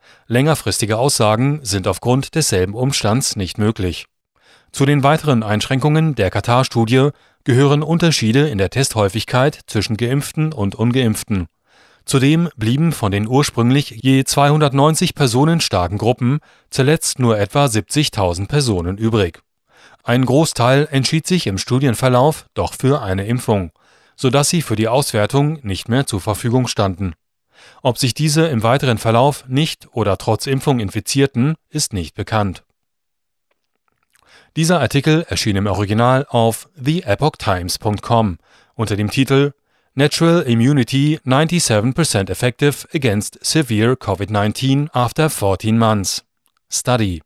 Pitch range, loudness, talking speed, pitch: 105-145 Hz, -16 LUFS, 120 wpm, 125 Hz